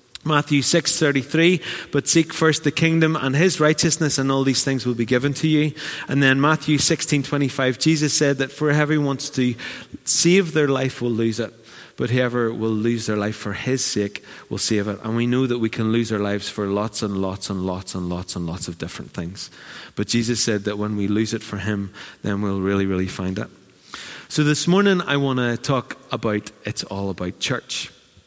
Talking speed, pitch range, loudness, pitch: 210 wpm, 105-145 Hz, -21 LUFS, 125 Hz